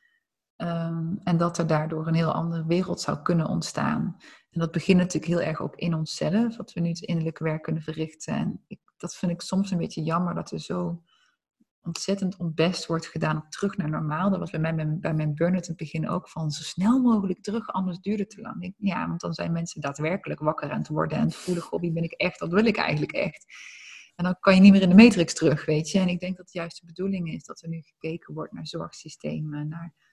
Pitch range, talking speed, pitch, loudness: 160-185 Hz, 245 wpm, 170 Hz, -26 LUFS